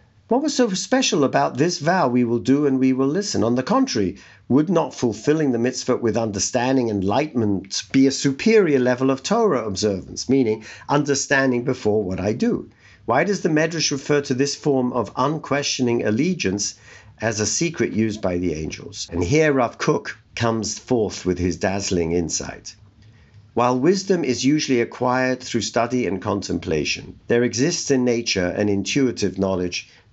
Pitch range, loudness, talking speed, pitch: 105-140 Hz, -21 LUFS, 165 wpm, 120 Hz